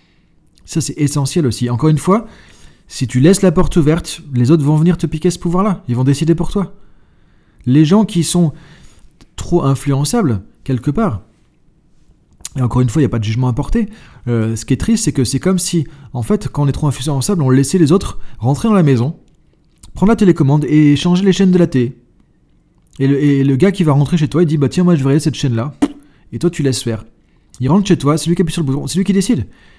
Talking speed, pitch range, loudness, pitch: 240 wpm, 135-180 Hz, -14 LUFS, 150 Hz